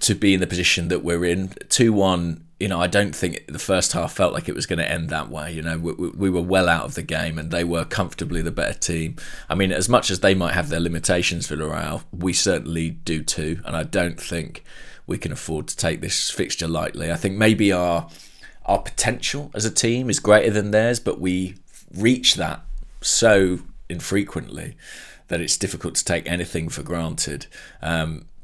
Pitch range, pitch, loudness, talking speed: 85-100 Hz, 90 Hz, -22 LUFS, 210 wpm